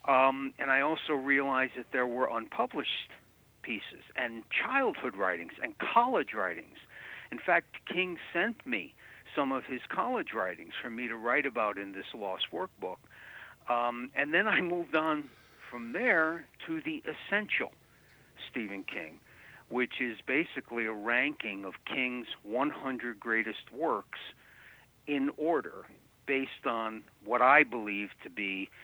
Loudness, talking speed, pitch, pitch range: -32 LUFS, 140 wpm, 130 Hz, 115-150 Hz